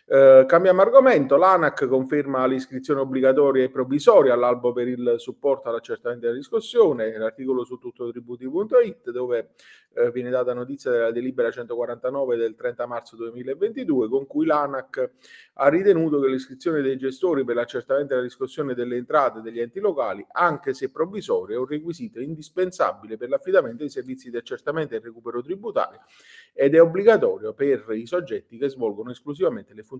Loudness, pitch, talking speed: -22 LUFS, 145 Hz, 160 wpm